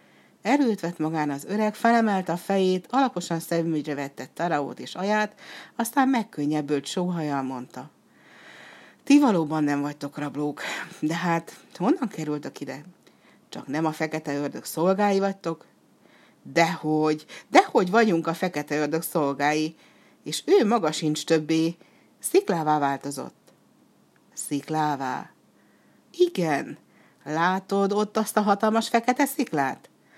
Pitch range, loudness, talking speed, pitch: 150-215 Hz, -25 LUFS, 115 wpm, 165 Hz